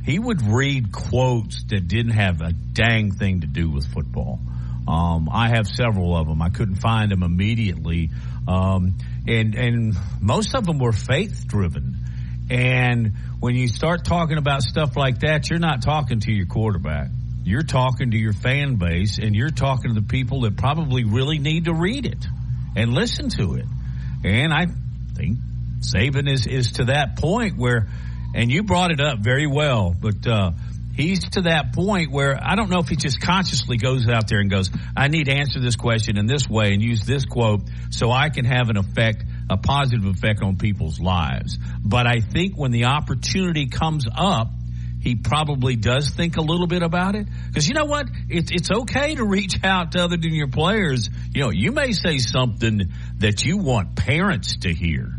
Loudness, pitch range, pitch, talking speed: -21 LUFS, 95-140 Hz, 115 Hz, 190 wpm